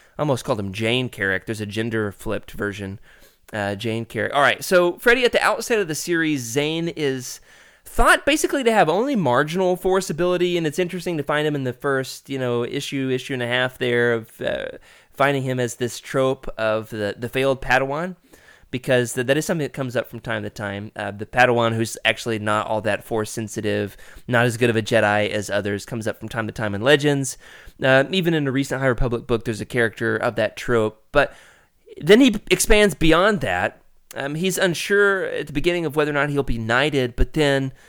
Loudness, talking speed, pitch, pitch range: -21 LUFS, 215 wpm, 130 Hz, 115-155 Hz